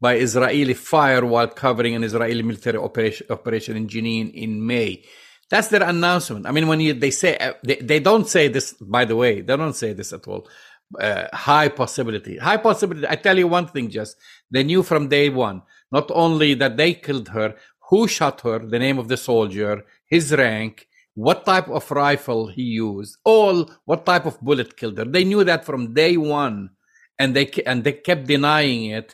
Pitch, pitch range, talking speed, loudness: 135 Hz, 115-160 Hz, 195 wpm, -19 LUFS